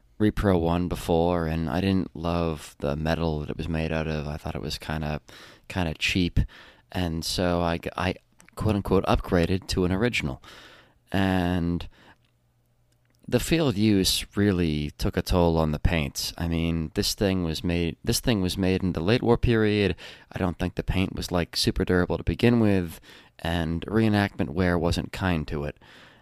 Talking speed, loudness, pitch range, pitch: 180 wpm, -26 LUFS, 80-100 Hz, 90 Hz